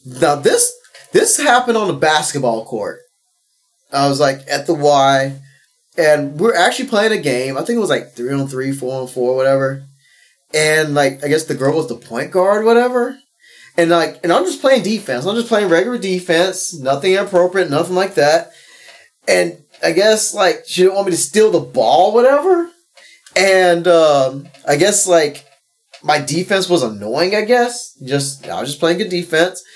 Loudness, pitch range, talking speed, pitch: -15 LUFS, 140-220 Hz, 185 wpm, 175 Hz